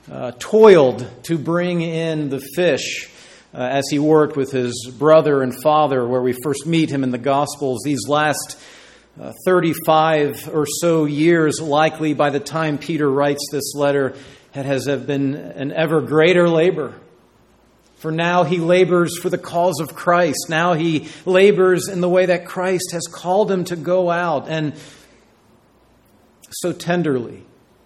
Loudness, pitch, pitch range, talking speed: -18 LUFS, 155 Hz, 140-175 Hz, 155 wpm